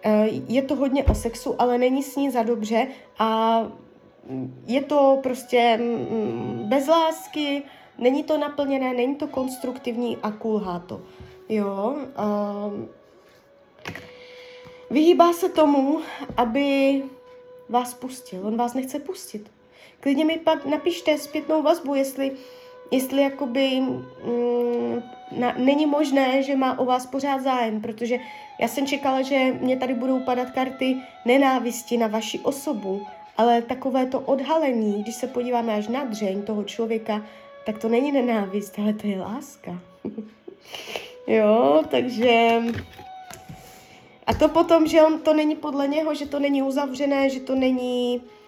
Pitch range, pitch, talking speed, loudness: 230-285 Hz, 260 Hz, 135 wpm, -23 LUFS